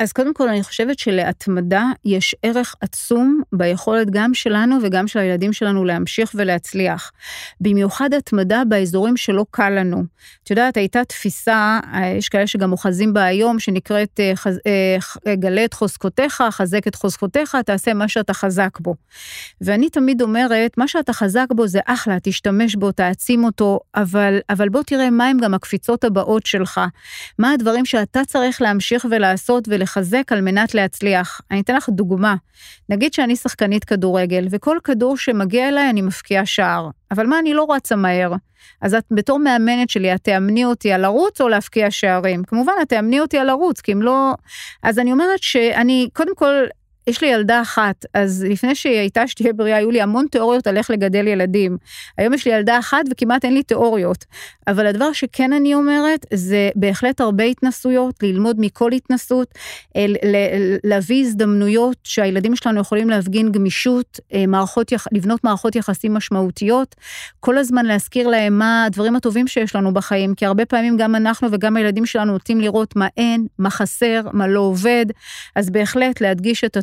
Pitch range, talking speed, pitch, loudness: 200-245 Hz, 165 wpm, 220 Hz, -17 LUFS